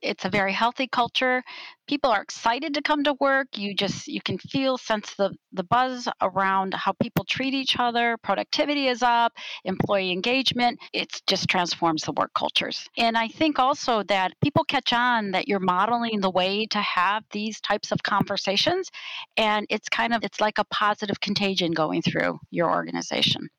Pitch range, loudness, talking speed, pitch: 195-255 Hz, -24 LUFS, 180 wpm, 215 Hz